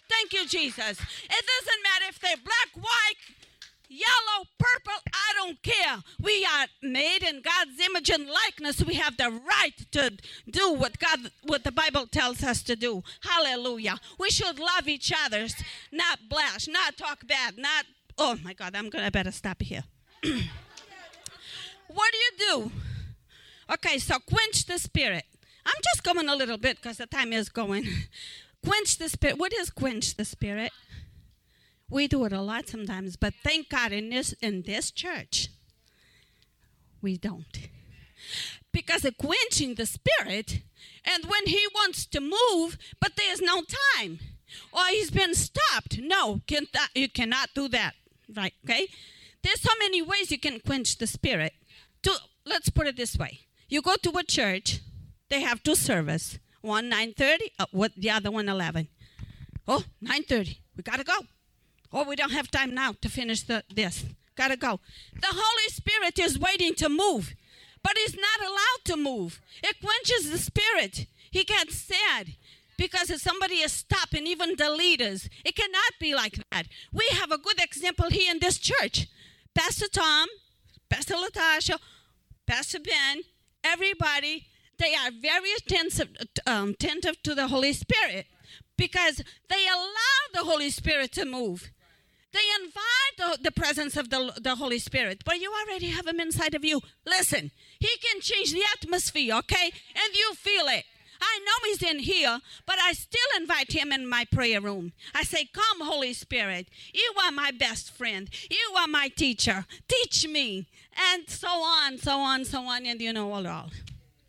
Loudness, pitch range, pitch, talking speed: -26 LUFS, 245-370 Hz, 315 Hz, 175 wpm